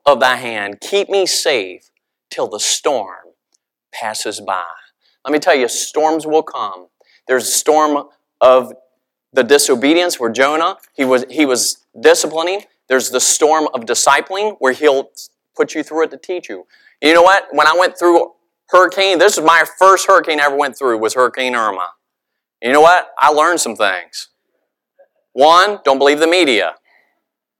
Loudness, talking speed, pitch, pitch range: -13 LUFS, 165 wpm, 155 Hz, 130-180 Hz